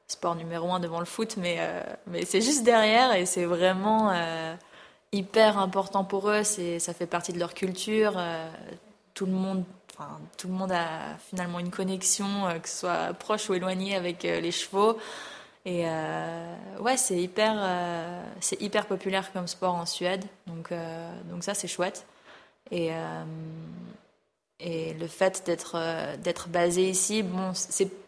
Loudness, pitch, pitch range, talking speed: -28 LUFS, 185 Hz, 170-195 Hz, 170 wpm